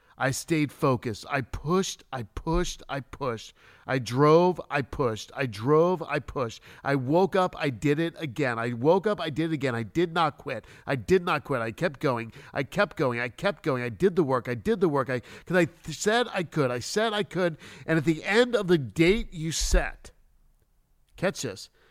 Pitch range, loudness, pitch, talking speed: 130-180 Hz, -27 LUFS, 155 Hz, 215 wpm